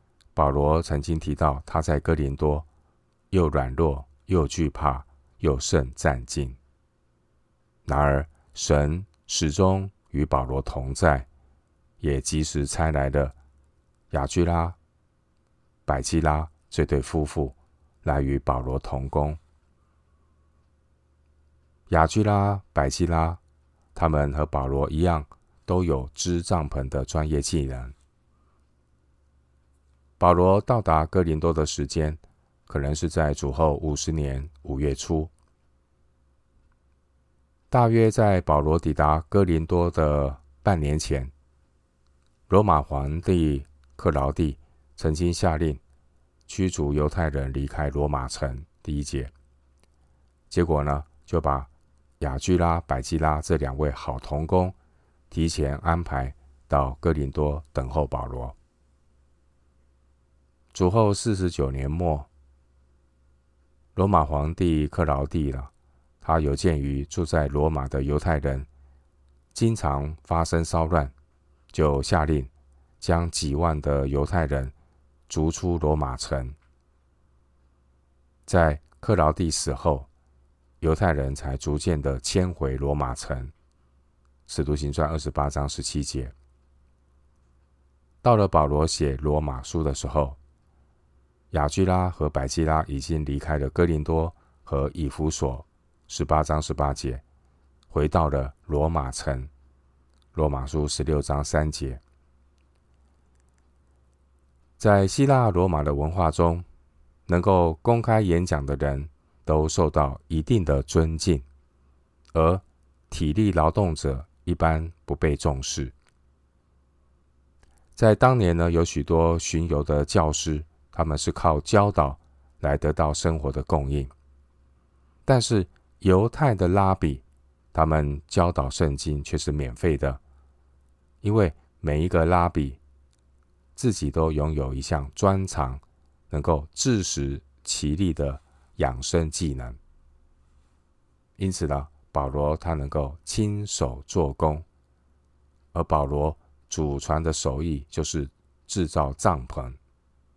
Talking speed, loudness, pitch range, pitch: 170 characters per minute, -25 LUFS, 65-80 Hz, 75 Hz